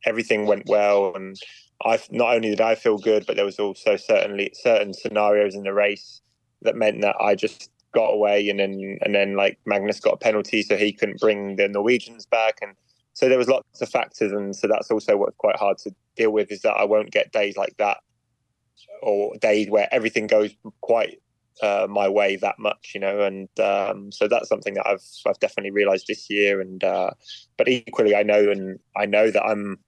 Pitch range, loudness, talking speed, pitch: 100-115 Hz, -22 LUFS, 210 wpm, 105 Hz